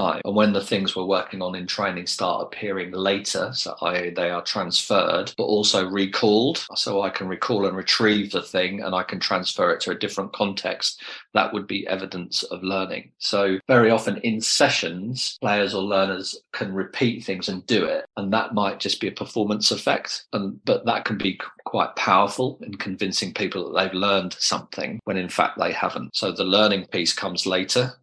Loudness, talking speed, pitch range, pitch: -23 LUFS, 195 wpm, 95-105 Hz, 100 Hz